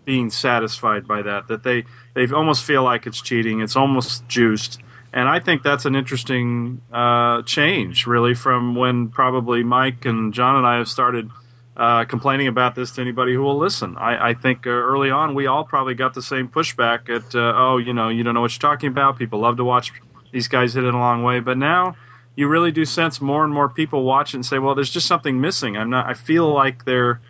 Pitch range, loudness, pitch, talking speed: 120-135 Hz, -19 LUFS, 125 Hz, 225 wpm